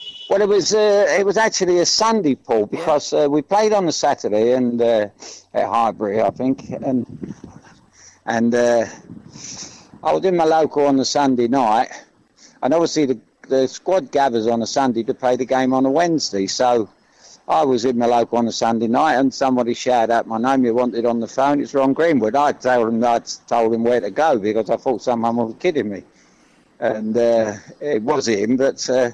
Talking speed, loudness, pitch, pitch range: 200 wpm, -18 LUFS, 130 Hz, 115-145 Hz